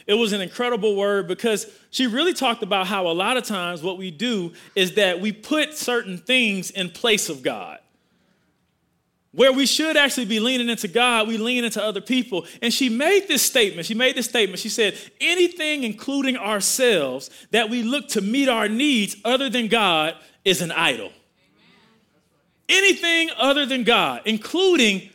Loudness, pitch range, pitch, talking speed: -20 LUFS, 200-260 Hz, 230 Hz, 175 wpm